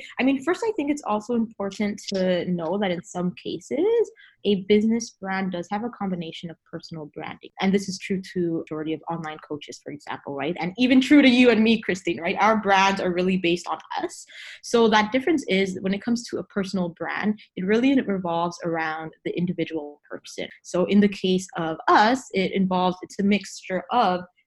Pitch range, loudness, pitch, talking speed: 175-225 Hz, -23 LUFS, 190 Hz, 200 wpm